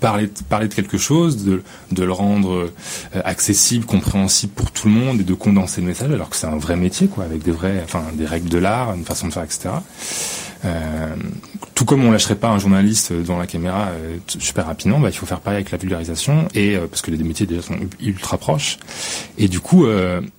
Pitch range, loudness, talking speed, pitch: 90-105 Hz, -18 LUFS, 225 wpm, 95 Hz